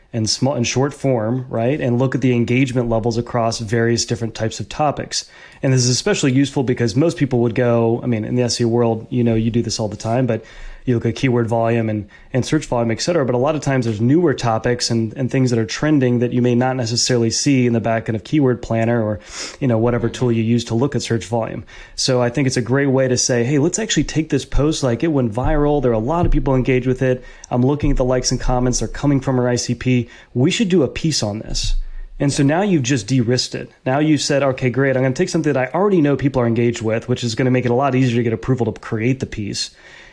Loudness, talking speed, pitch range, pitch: -18 LUFS, 270 wpm, 115-135 Hz, 125 Hz